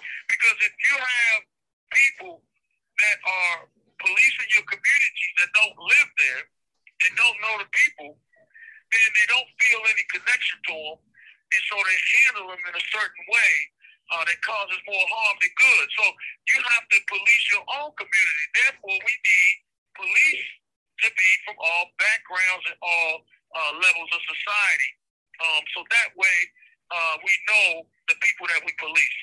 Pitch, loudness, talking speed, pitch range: 205 Hz, -20 LUFS, 160 wpm, 175-240 Hz